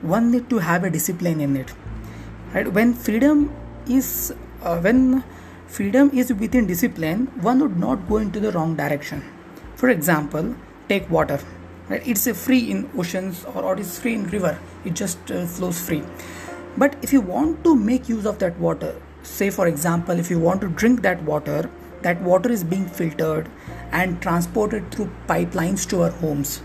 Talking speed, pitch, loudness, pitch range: 180 wpm, 190 Hz, -21 LUFS, 170-240 Hz